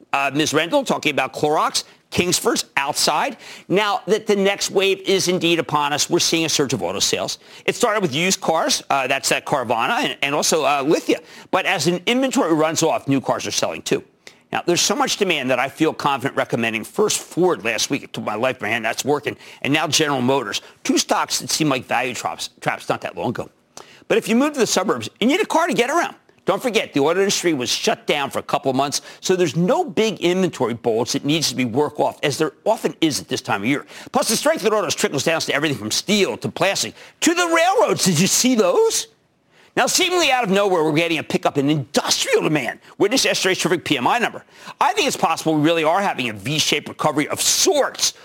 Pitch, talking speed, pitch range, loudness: 170 Hz, 230 wpm, 145-205 Hz, -19 LUFS